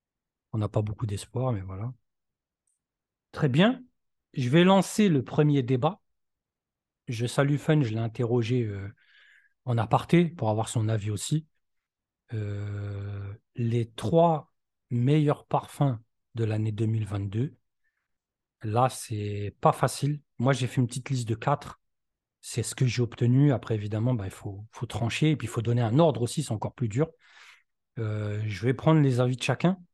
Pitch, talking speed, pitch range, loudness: 120 Hz, 165 wpm, 110-145 Hz, -27 LUFS